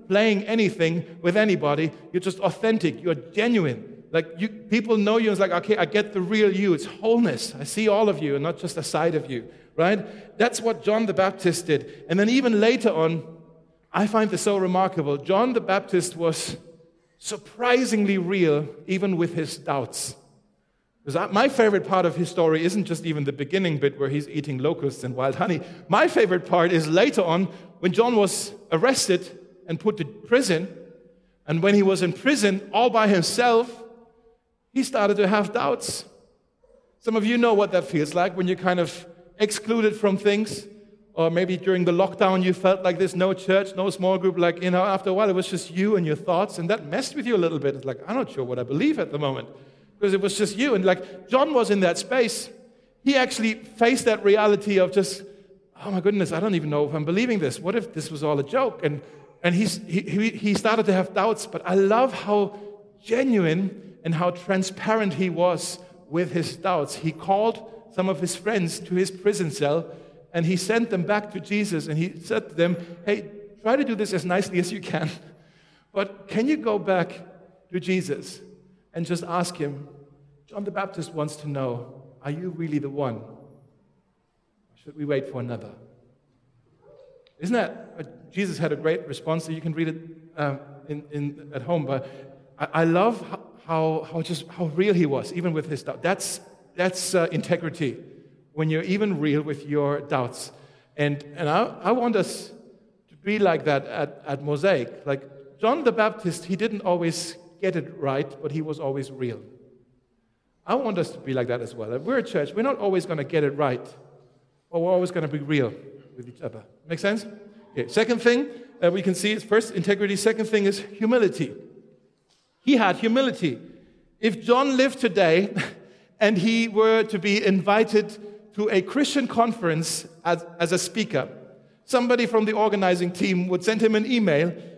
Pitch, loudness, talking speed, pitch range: 185 Hz, -24 LUFS, 195 wpm, 160-210 Hz